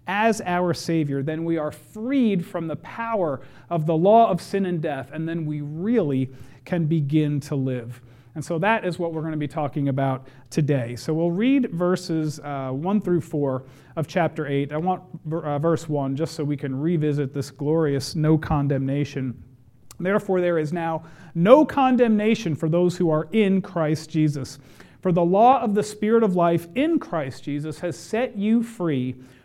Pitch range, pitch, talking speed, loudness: 145-180 Hz, 160 Hz, 185 wpm, -23 LUFS